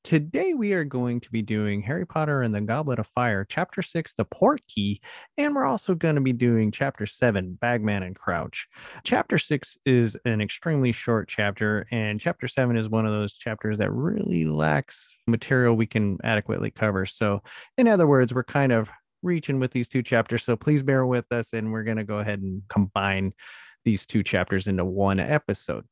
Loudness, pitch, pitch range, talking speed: -25 LUFS, 115 Hz, 105-135 Hz, 195 wpm